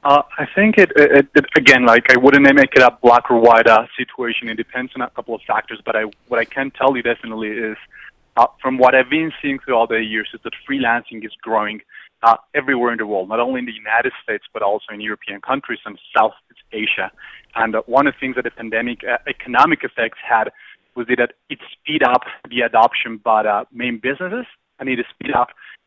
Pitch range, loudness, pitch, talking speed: 115-135 Hz, -16 LUFS, 120 Hz, 225 wpm